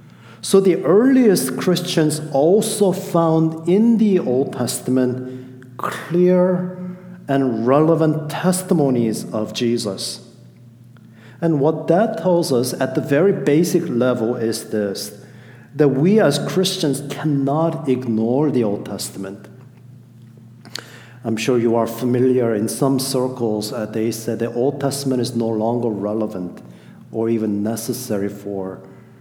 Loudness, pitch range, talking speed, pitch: -18 LUFS, 115-160 Hz, 120 wpm, 130 Hz